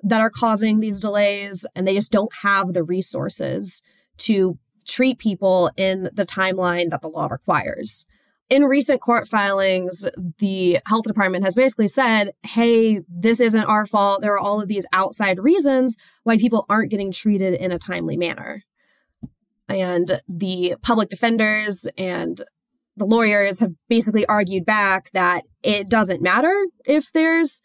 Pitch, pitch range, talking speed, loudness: 205 Hz, 190-230 Hz, 150 wpm, -19 LUFS